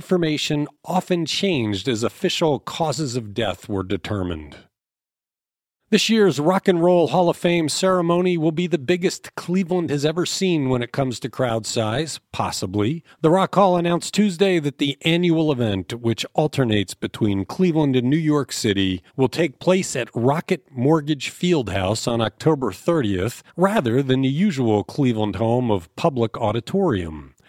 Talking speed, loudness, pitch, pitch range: 155 wpm, -21 LUFS, 145 Hz, 115-175 Hz